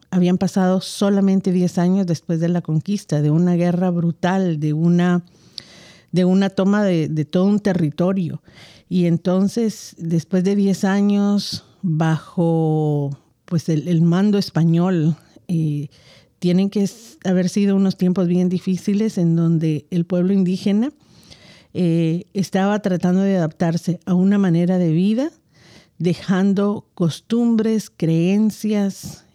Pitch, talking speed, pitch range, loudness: 180 Hz, 125 wpm, 170-195 Hz, -19 LUFS